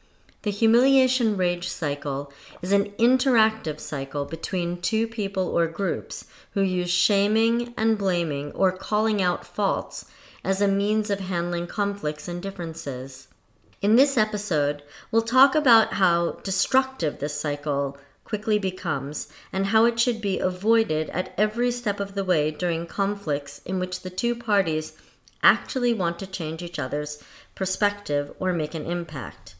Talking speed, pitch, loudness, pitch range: 145 wpm, 185 Hz, -25 LUFS, 155-215 Hz